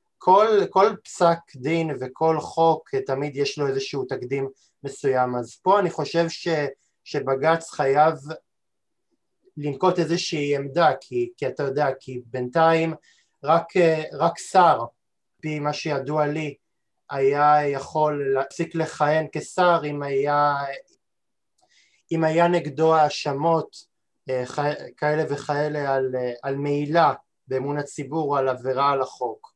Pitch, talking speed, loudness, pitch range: 150 Hz, 115 wpm, -23 LUFS, 140-165 Hz